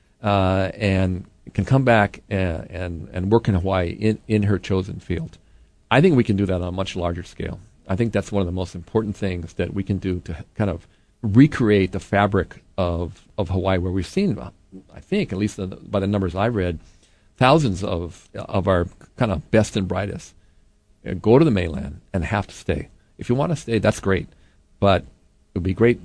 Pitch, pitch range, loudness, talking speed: 95 Hz, 90-105 Hz, -22 LUFS, 205 wpm